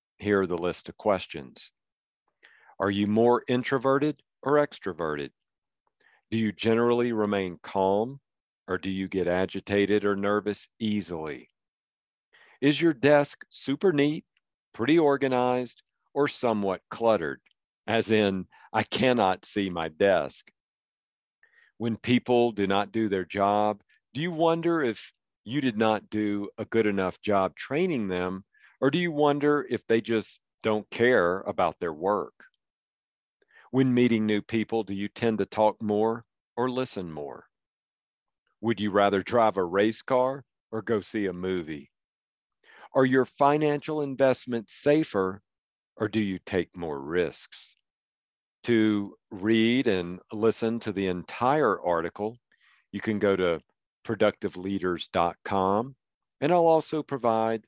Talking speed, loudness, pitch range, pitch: 135 wpm, -27 LUFS, 100-125 Hz, 110 Hz